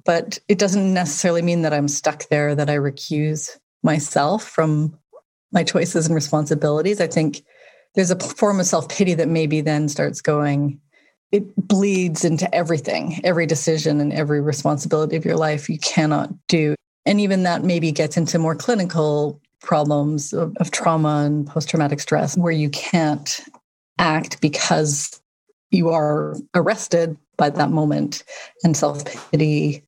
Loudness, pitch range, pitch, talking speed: -20 LUFS, 150-175 Hz, 160 Hz, 155 wpm